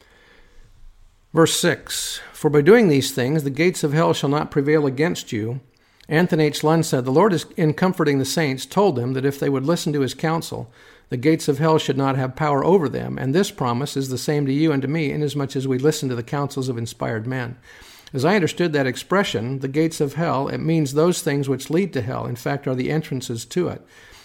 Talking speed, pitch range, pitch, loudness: 230 wpm, 130-160 Hz, 145 Hz, -21 LUFS